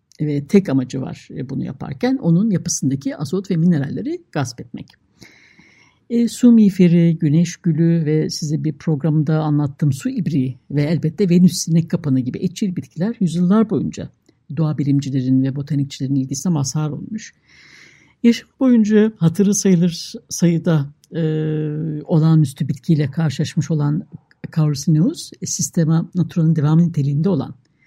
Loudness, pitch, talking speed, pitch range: -18 LUFS, 160 Hz, 125 wpm, 150-180 Hz